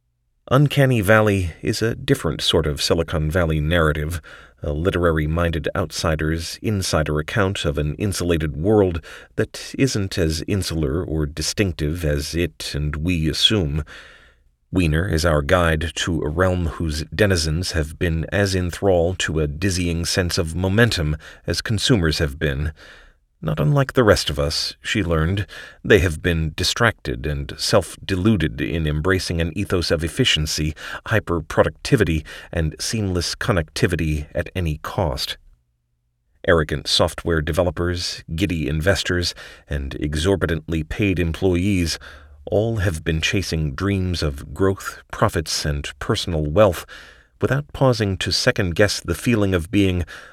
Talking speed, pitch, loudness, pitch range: 130 wpm, 85 Hz, -21 LUFS, 75-95 Hz